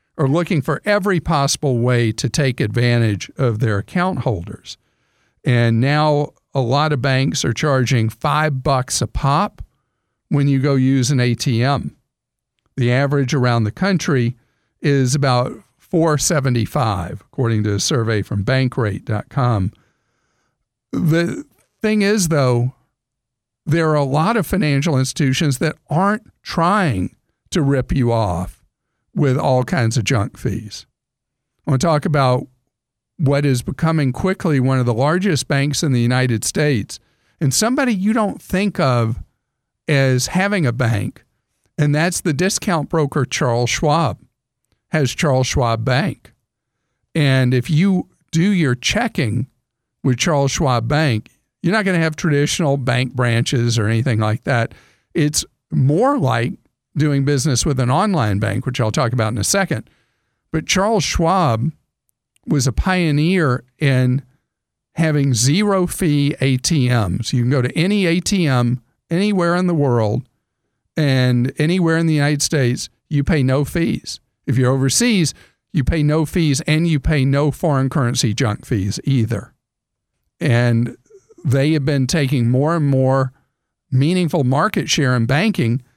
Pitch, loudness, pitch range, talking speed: 135 Hz, -18 LUFS, 120-160 Hz, 145 wpm